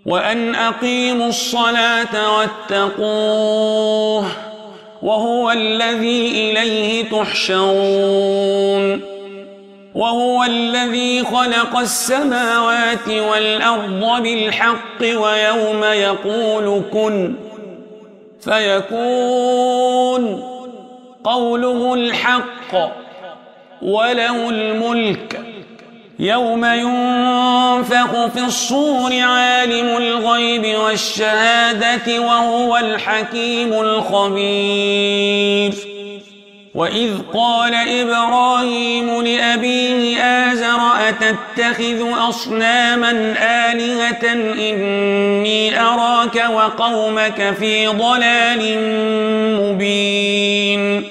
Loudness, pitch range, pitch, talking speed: -15 LUFS, 215-240 Hz, 230 Hz, 55 wpm